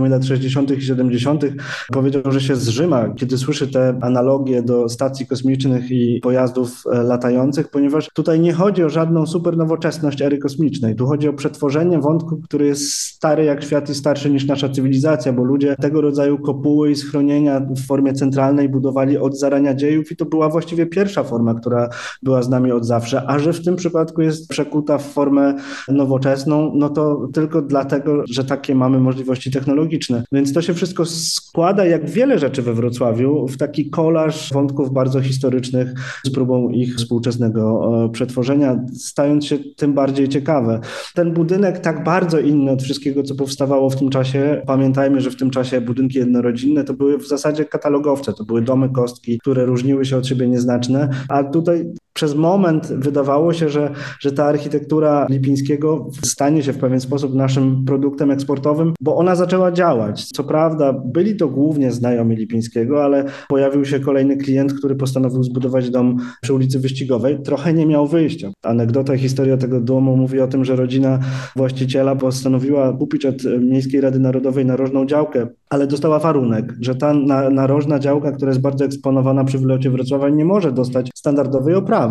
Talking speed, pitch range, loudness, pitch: 170 wpm, 130-150 Hz, -17 LUFS, 140 Hz